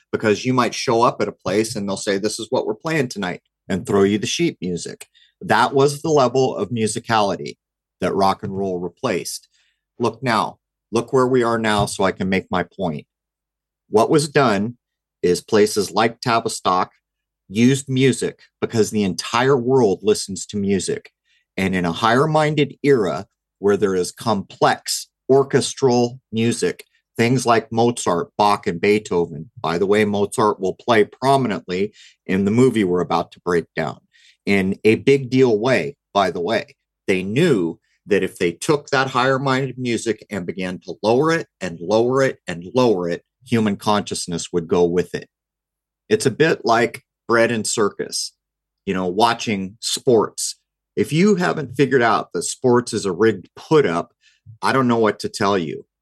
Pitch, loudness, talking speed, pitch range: 115 Hz, -19 LUFS, 170 wpm, 100-130 Hz